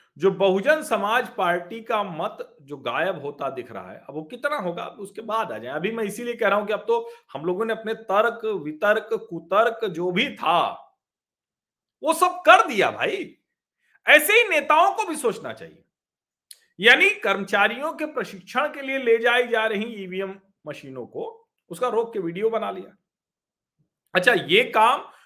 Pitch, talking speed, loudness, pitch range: 220 Hz, 175 wpm, -22 LUFS, 195-290 Hz